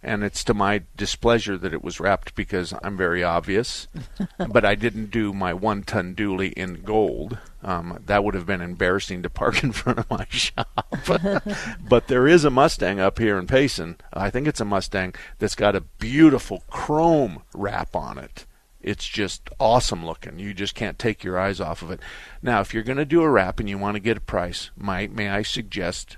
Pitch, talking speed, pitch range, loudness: 100 Hz, 205 wpm, 95-115 Hz, -23 LUFS